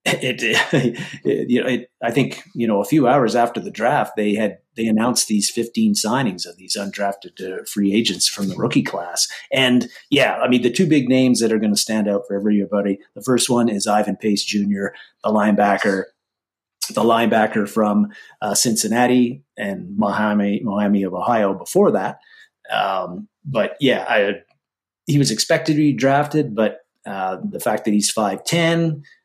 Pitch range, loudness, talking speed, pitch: 105-135 Hz, -19 LUFS, 180 wpm, 110 Hz